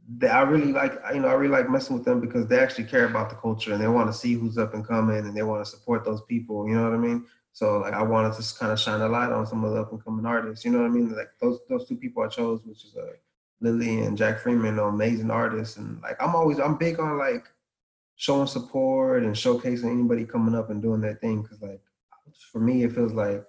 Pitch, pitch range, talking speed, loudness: 115 Hz, 110-155 Hz, 275 wpm, -25 LUFS